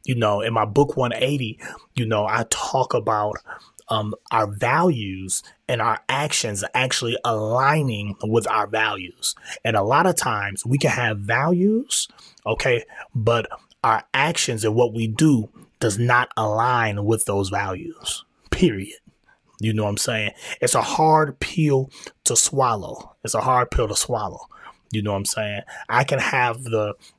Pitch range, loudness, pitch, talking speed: 105-130 Hz, -21 LUFS, 115 Hz, 160 wpm